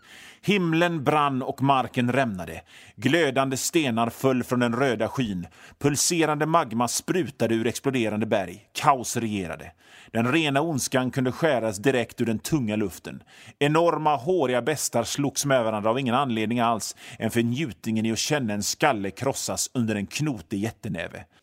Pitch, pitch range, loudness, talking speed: 125 Hz, 110-145 Hz, -25 LUFS, 145 wpm